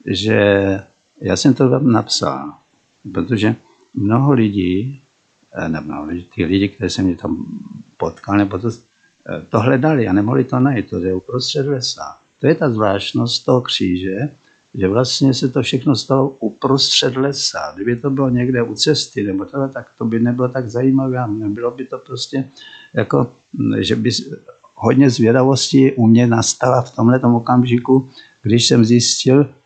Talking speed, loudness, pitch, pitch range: 150 wpm, -16 LUFS, 125 Hz, 110-135 Hz